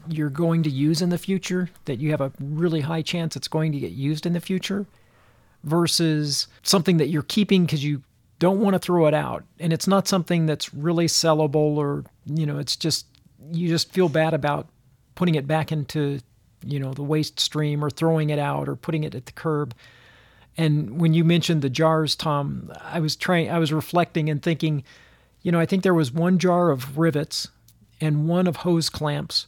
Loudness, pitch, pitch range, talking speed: -23 LUFS, 155 Hz, 145-170 Hz, 205 wpm